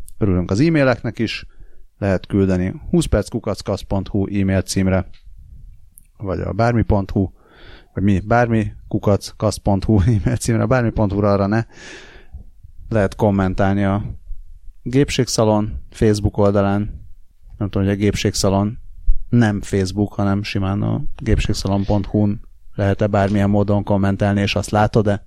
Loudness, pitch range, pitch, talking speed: -19 LUFS, 95-110 Hz, 100 Hz, 110 wpm